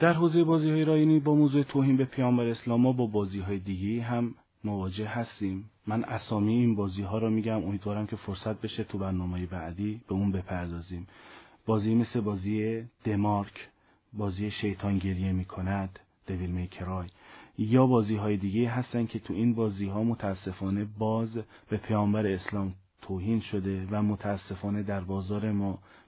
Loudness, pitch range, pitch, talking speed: -30 LUFS, 95-115 Hz, 105 Hz, 155 wpm